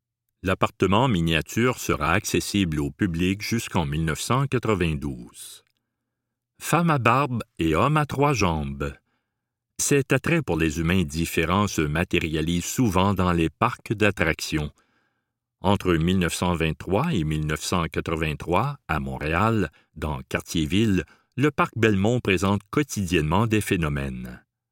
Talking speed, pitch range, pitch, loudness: 105 wpm, 80-115 Hz, 95 Hz, -24 LUFS